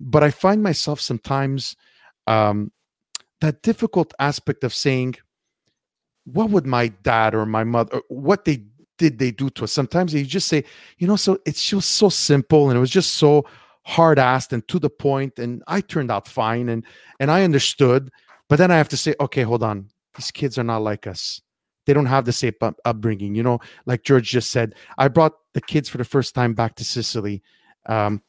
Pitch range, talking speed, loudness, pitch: 115-155 Hz, 205 wpm, -20 LUFS, 135 Hz